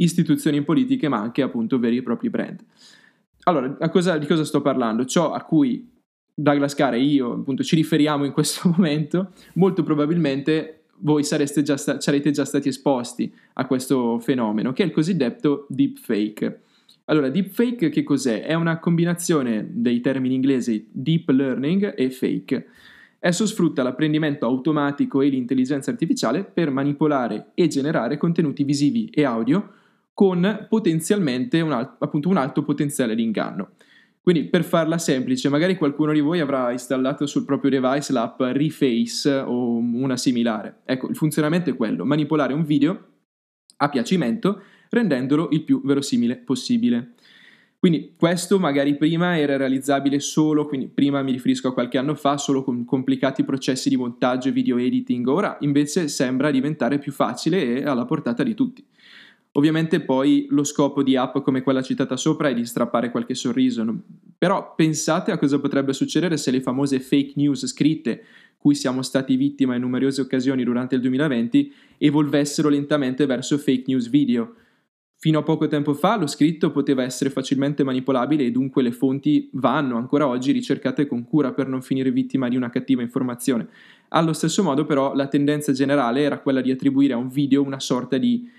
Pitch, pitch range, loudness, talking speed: 145 Hz, 135-165 Hz, -21 LUFS, 165 wpm